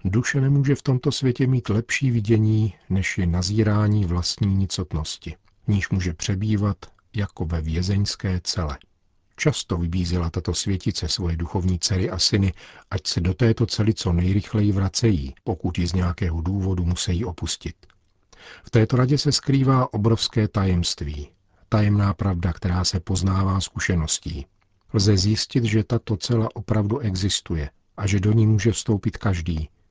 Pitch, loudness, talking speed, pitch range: 100 Hz, -23 LUFS, 140 wpm, 90-110 Hz